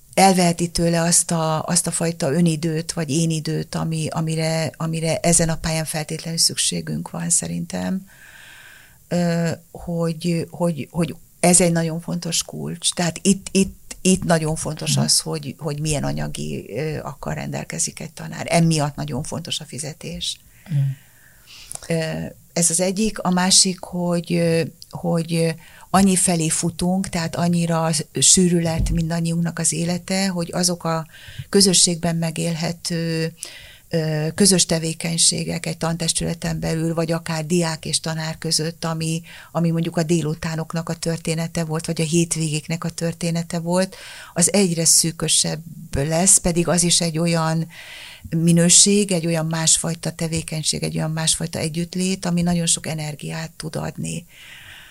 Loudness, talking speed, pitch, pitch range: -20 LUFS, 130 wpm, 165 Hz, 160-170 Hz